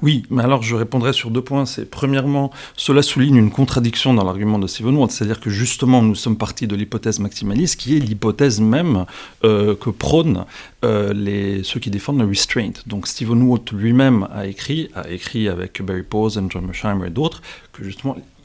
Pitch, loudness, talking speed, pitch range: 115 Hz, -18 LUFS, 195 wpm, 100-130 Hz